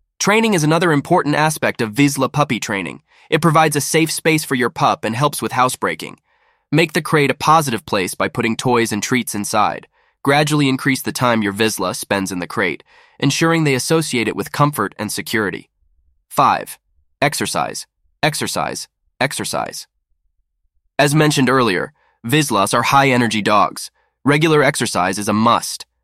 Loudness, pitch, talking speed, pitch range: -17 LUFS, 125 Hz, 155 wpm, 105-150 Hz